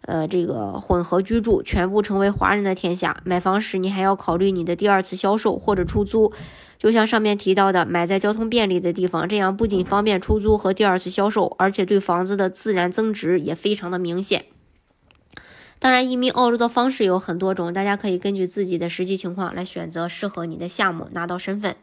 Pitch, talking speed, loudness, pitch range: 190 Hz, 330 characters per minute, -21 LUFS, 180-205 Hz